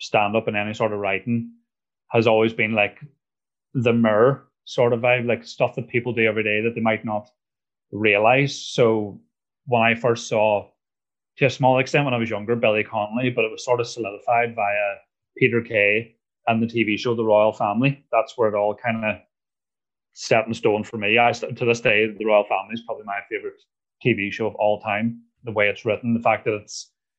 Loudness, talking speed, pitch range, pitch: -21 LUFS, 210 wpm, 105-120 Hz, 115 Hz